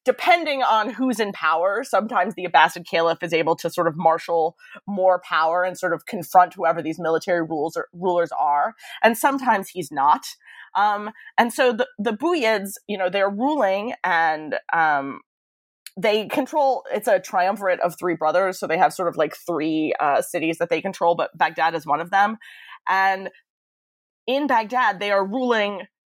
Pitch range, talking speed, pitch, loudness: 170-220 Hz, 175 wpm, 185 Hz, -21 LUFS